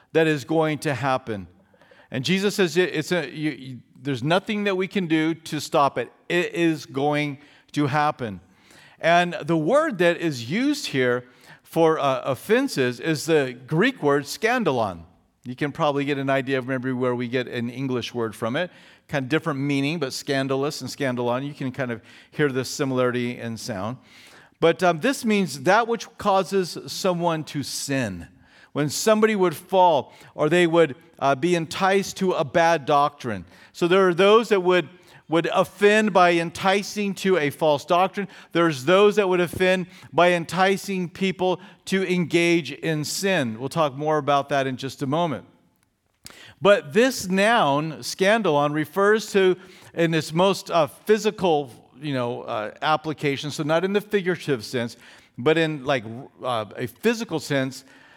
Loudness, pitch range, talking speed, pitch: -23 LUFS, 135-185 Hz, 165 wpm, 155 Hz